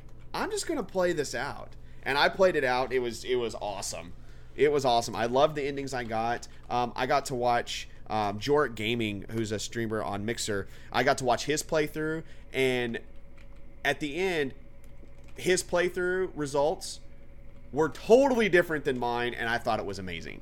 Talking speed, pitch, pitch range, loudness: 185 wpm, 125 Hz, 110-155 Hz, -29 LUFS